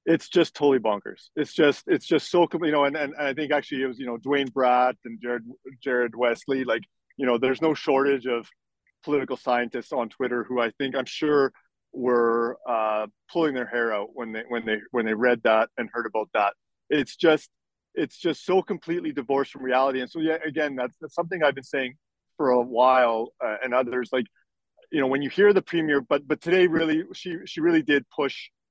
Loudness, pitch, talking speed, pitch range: -25 LUFS, 135 Hz, 215 wpm, 125-155 Hz